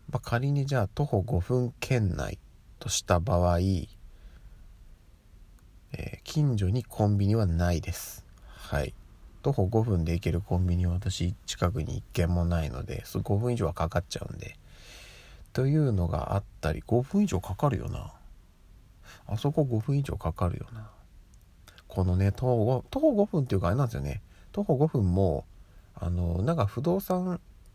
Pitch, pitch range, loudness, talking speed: 95 Hz, 90-120 Hz, -29 LUFS, 275 characters per minute